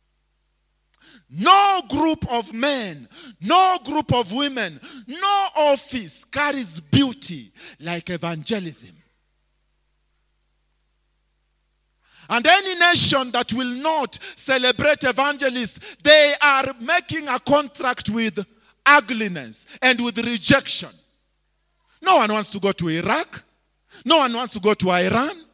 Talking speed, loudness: 110 wpm, -18 LUFS